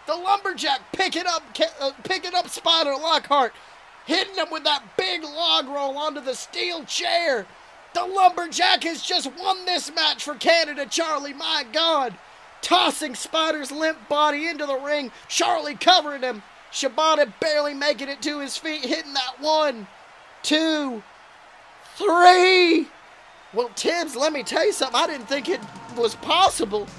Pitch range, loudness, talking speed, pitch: 285-340 Hz, -22 LUFS, 150 wpm, 310 Hz